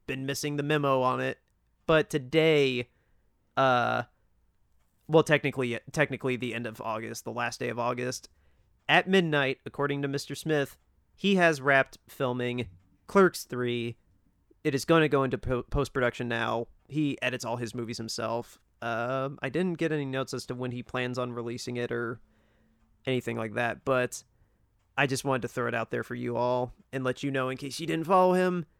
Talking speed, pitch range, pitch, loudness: 185 wpm, 115-140 Hz, 125 Hz, -29 LUFS